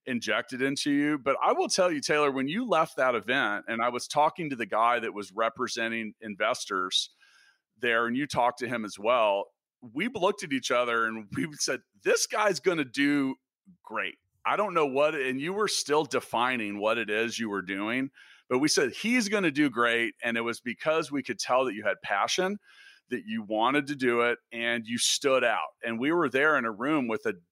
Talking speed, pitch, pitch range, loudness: 220 wpm, 135 Hz, 115-155 Hz, -28 LUFS